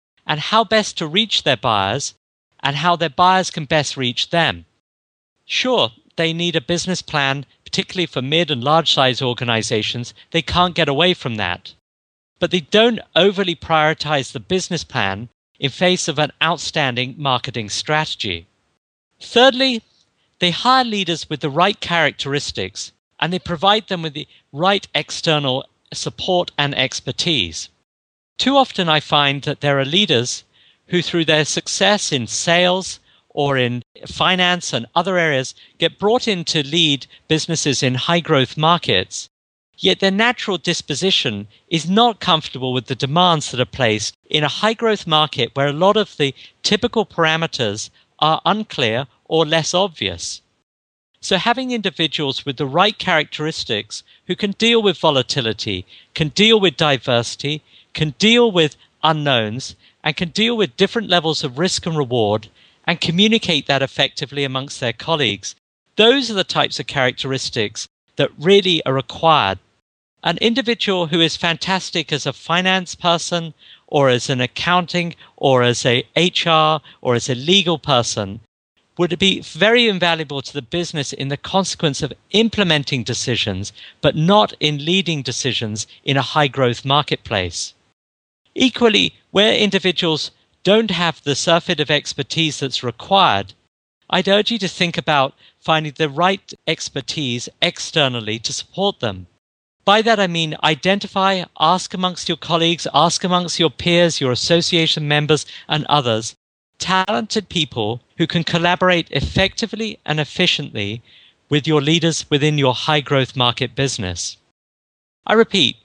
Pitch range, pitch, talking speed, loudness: 125-180 Hz, 155 Hz, 145 wpm, -17 LUFS